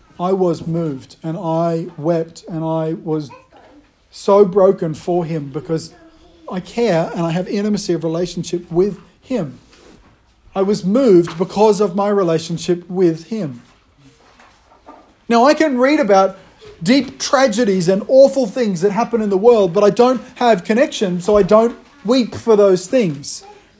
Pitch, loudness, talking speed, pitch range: 195 Hz, -16 LUFS, 150 wpm, 170-235 Hz